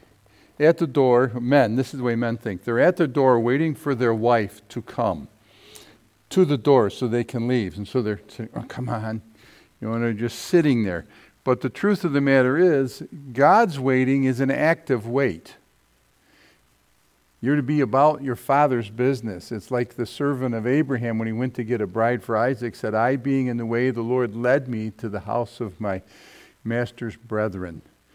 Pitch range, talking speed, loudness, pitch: 115-135 Hz, 200 wpm, -22 LUFS, 125 Hz